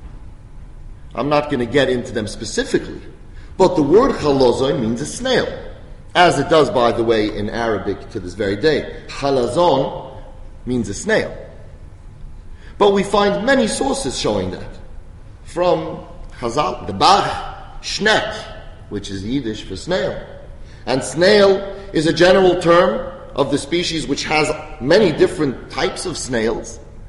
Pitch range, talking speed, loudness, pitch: 105-175 Hz, 140 wpm, -17 LUFS, 140 Hz